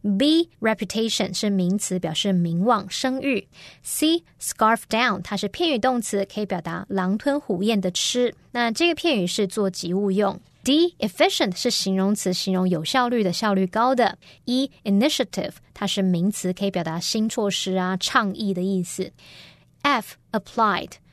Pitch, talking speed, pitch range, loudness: 205 Hz, 330 characters per minute, 185-245 Hz, -23 LUFS